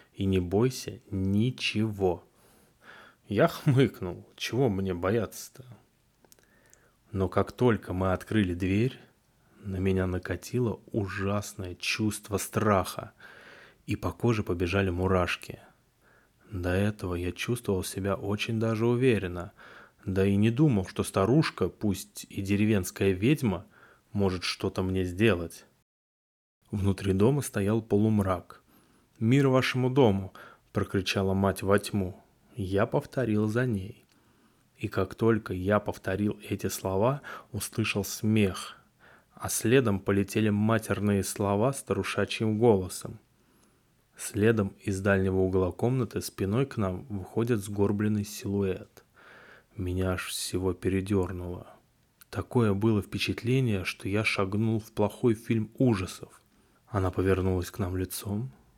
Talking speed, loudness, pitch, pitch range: 110 wpm, -28 LUFS, 100 Hz, 95-115 Hz